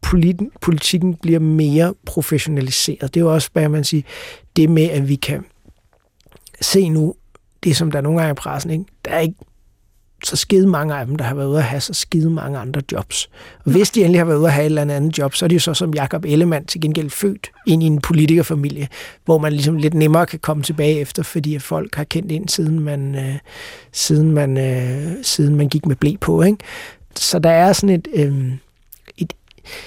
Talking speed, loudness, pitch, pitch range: 220 wpm, -17 LUFS, 155 Hz, 145-170 Hz